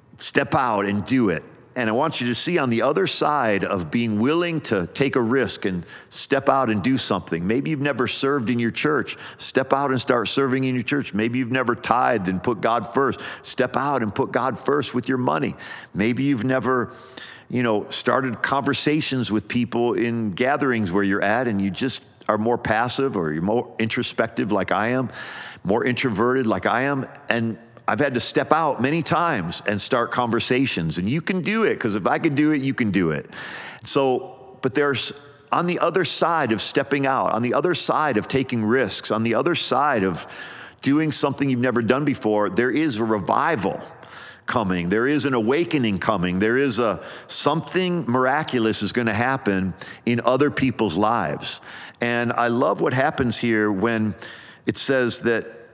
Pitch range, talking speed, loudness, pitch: 110-140 Hz, 195 wpm, -22 LUFS, 125 Hz